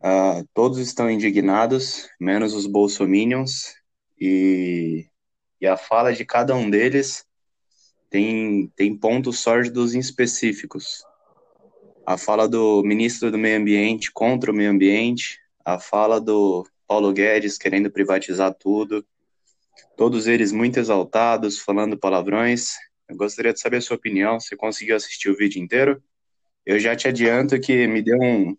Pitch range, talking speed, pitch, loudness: 100-120 Hz, 140 wpm, 110 Hz, -20 LUFS